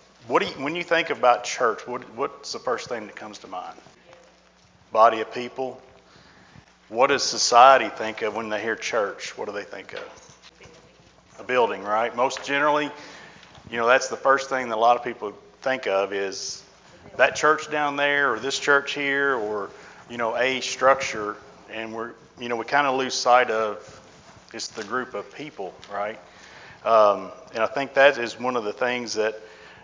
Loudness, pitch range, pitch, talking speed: -23 LUFS, 105-140 Hz, 125 Hz, 185 wpm